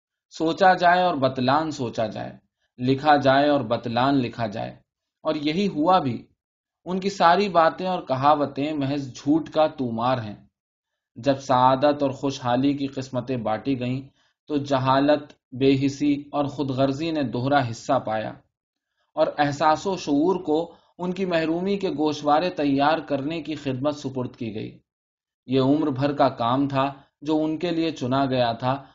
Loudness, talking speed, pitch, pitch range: -23 LUFS, 160 wpm, 140 Hz, 130-155 Hz